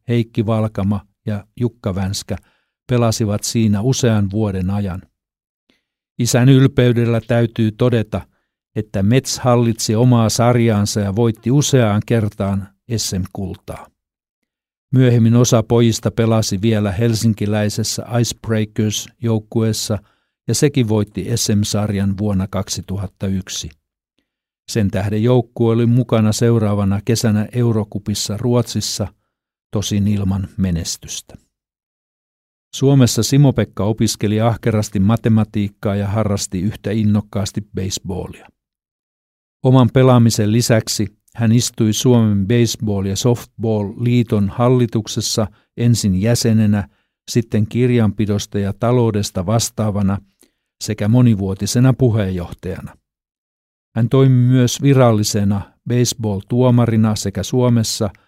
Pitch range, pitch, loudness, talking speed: 100-120 Hz, 110 Hz, -17 LUFS, 90 wpm